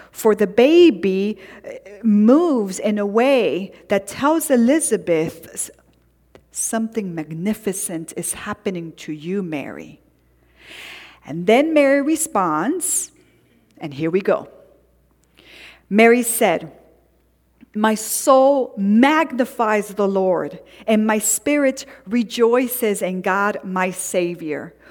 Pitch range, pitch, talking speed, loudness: 185-250 Hz, 215 Hz, 95 wpm, -18 LUFS